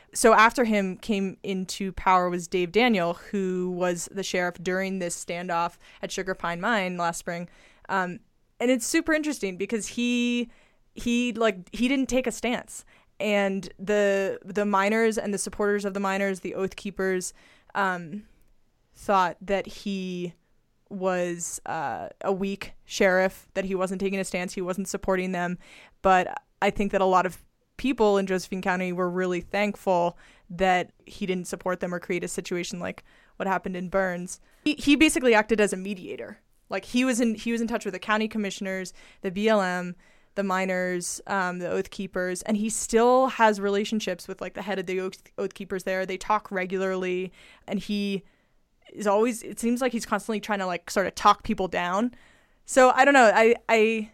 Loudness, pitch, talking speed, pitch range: -26 LUFS, 195 Hz, 180 wpm, 185-215 Hz